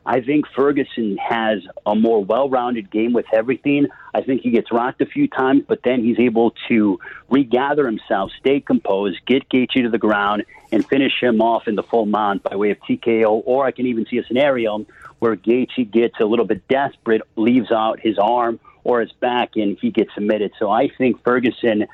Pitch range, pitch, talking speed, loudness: 110-130 Hz, 115 Hz, 200 wpm, -18 LUFS